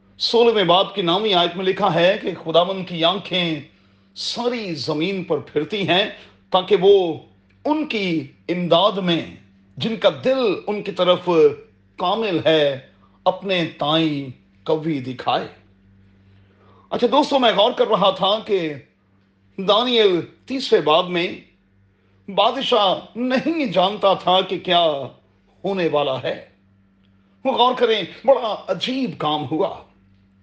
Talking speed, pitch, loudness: 125 wpm, 175 Hz, -19 LUFS